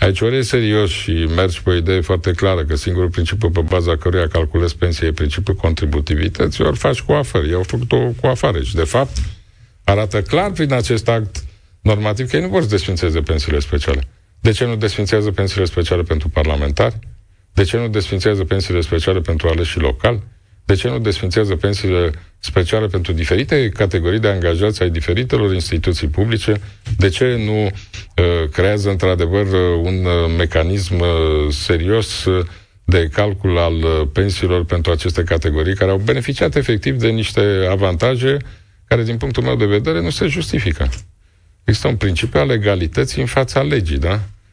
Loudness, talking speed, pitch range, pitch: -17 LUFS, 165 wpm, 85-105 Hz, 95 Hz